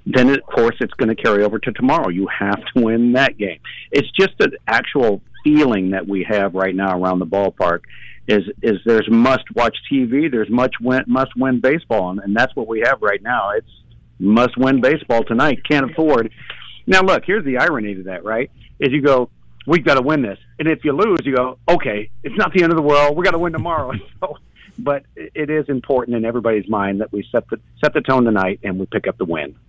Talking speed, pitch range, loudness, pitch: 230 wpm, 105-145 Hz, -17 LUFS, 125 Hz